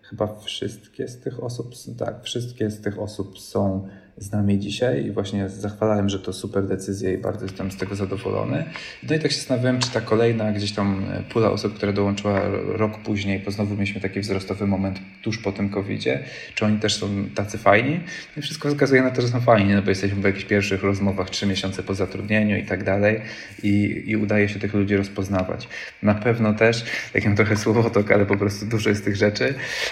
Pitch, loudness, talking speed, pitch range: 100 Hz, -23 LUFS, 205 wpm, 100-110 Hz